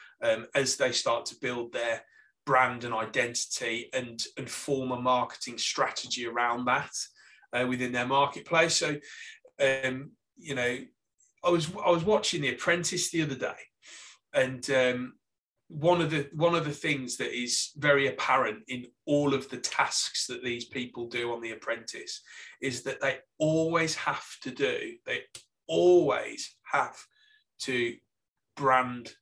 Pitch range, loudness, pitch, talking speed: 125-165 Hz, -29 LUFS, 135 Hz, 150 wpm